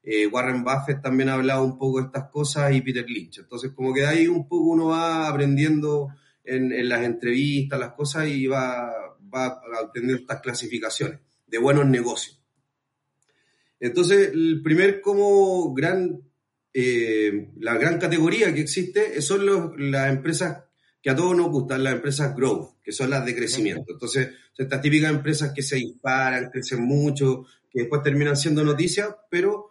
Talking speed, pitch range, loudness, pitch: 170 wpm, 130-160 Hz, -23 LUFS, 140 Hz